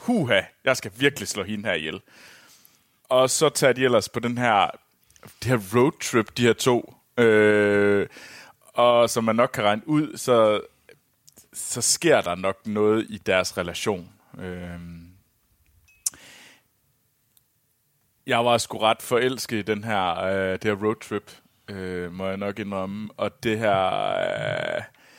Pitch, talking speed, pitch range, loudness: 110 Hz, 135 wpm, 100-120 Hz, -23 LUFS